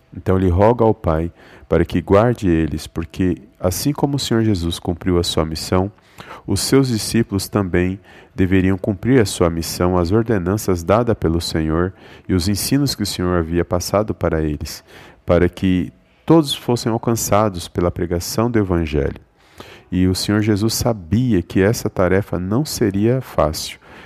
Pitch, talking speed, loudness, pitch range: 95 Hz, 155 wpm, -18 LUFS, 85-110 Hz